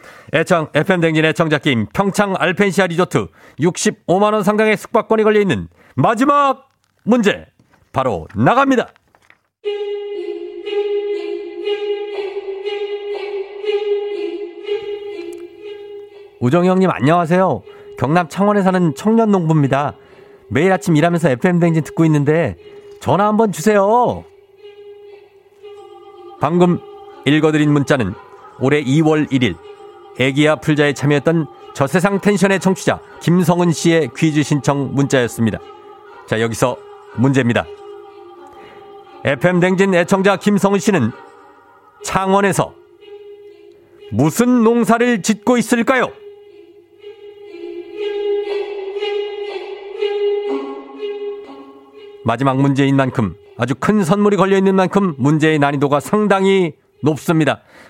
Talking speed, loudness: 215 characters per minute, -16 LUFS